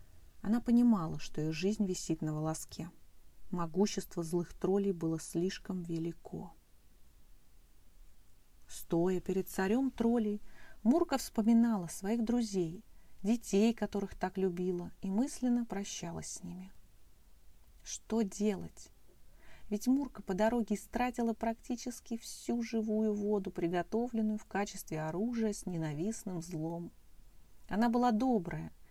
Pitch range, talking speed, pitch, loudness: 160-225 Hz, 110 wpm, 195 Hz, -35 LUFS